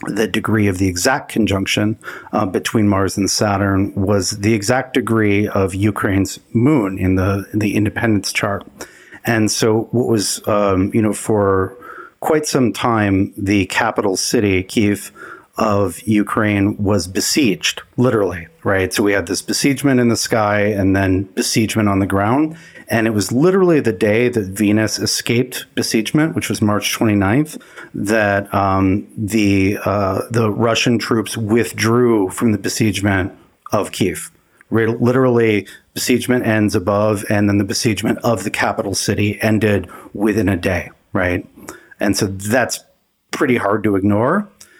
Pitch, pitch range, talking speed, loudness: 105 Hz, 100-115 Hz, 150 wpm, -17 LUFS